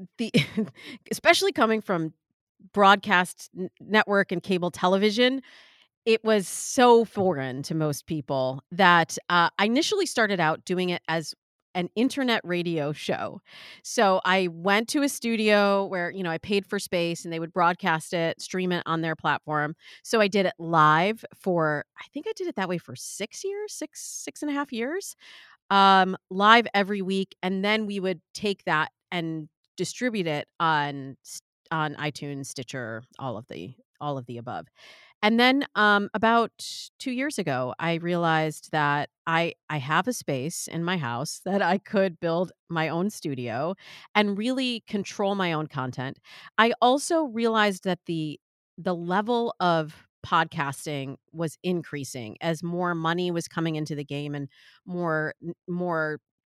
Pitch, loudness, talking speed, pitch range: 180 Hz, -25 LUFS, 160 wpm, 155-210 Hz